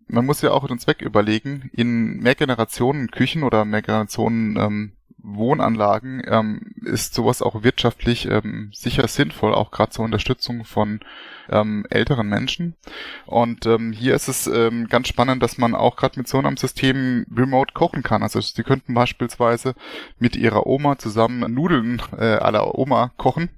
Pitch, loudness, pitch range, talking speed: 120 Hz, -20 LUFS, 110-130 Hz, 160 wpm